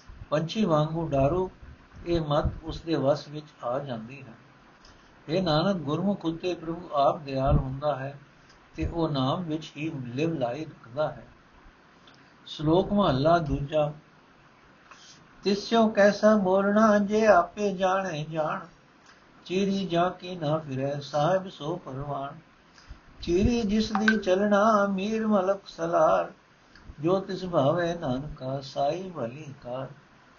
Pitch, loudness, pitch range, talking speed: 160 Hz, -27 LUFS, 145-190 Hz, 115 wpm